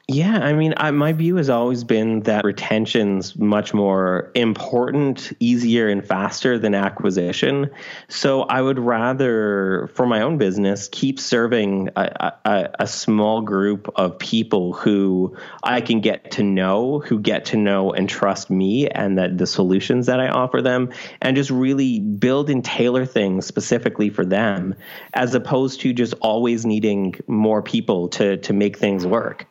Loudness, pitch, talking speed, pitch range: -19 LUFS, 110 Hz, 165 wpm, 100-130 Hz